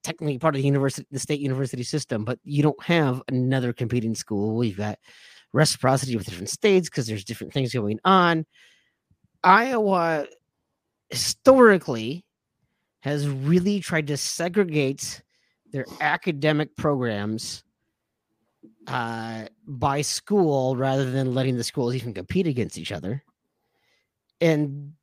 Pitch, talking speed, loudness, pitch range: 140 Hz, 125 wpm, -23 LUFS, 125-160 Hz